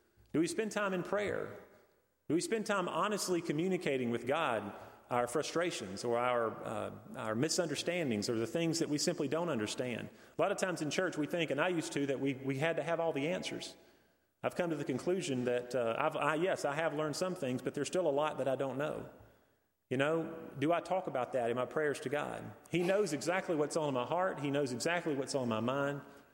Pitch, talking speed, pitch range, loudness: 150 Hz, 230 wpm, 135-175 Hz, -35 LUFS